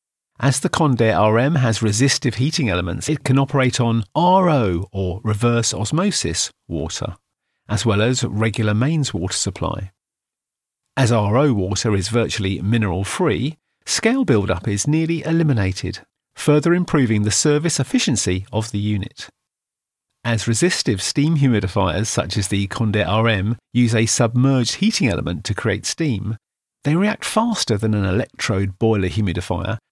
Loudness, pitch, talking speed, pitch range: -19 LUFS, 115 Hz, 140 wpm, 105-140 Hz